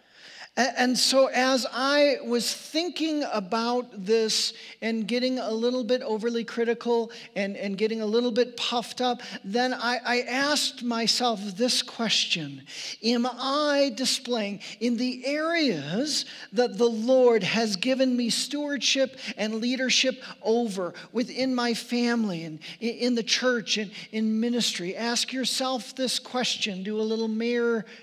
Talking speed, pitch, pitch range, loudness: 135 wpm, 240 Hz, 220-255 Hz, -26 LUFS